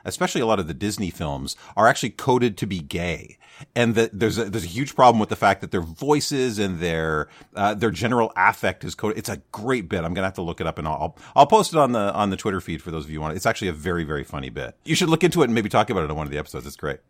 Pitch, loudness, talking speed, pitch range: 100 Hz, -22 LUFS, 310 wpm, 80-115 Hz